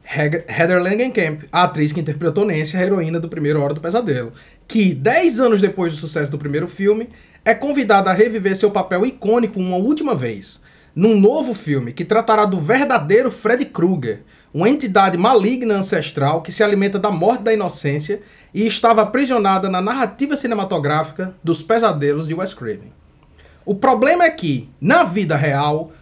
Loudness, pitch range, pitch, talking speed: -17 LUFS, 160-225 Hz, 195 Hz, 165 wpm